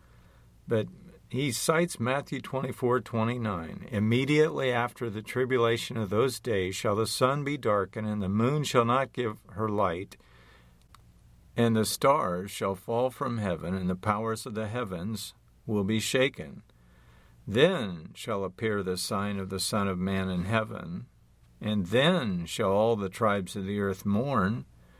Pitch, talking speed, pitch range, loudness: 110 Hz, 150 wpm, 95-125 Hz, -29 LUFS